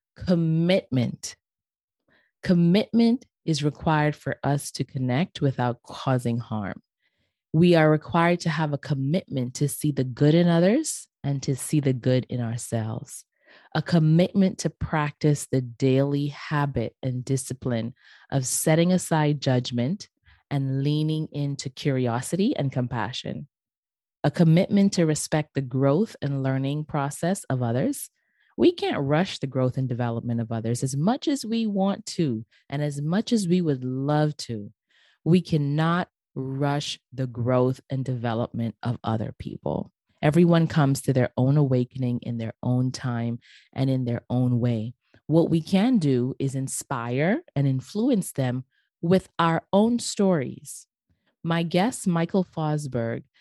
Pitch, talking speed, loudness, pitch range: 145 Hz, 140 wpm, -25 LUFS, 125-170 Hz